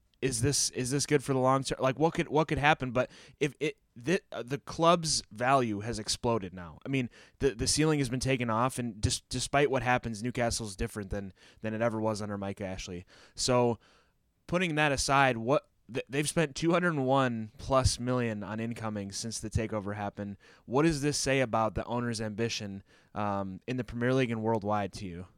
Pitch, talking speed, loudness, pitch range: 120 Hz, 195 wpm, -30 LUFS, 110-140 Hz